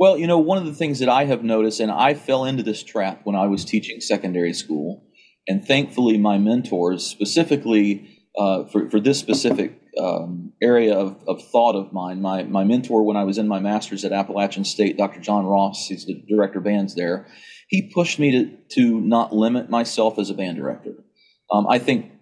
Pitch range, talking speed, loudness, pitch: 100-125 Hz, 205 wpm, -21 LUFS, 110 Hz